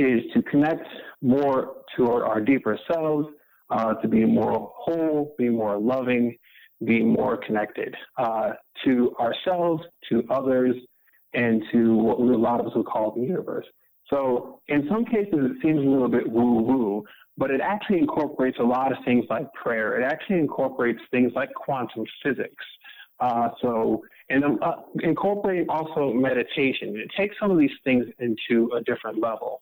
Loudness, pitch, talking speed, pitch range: -24 LUFS, 130 Hz, 160 wpm, 120-155 Hz